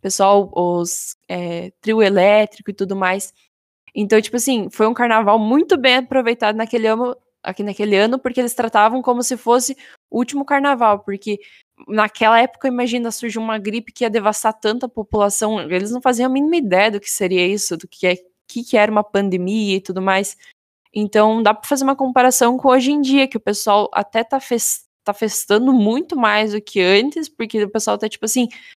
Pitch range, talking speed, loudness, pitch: 205-250 Hz, 195 wpm, -17 LUFS, 220 Hz